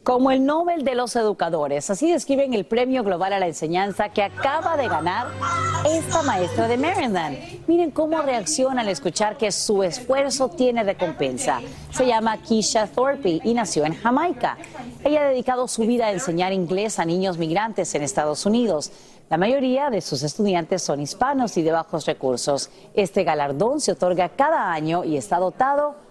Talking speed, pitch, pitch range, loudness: 170 wpm, 210 Hz, 175-260 Hz, -22 LUFS